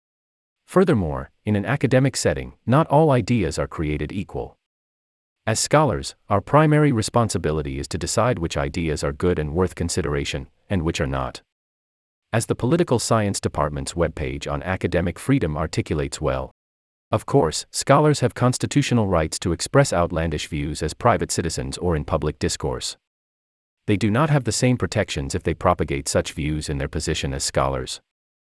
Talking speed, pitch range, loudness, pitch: 160 wpm, 75-115 Hz, -22 LUFS, 85 Hz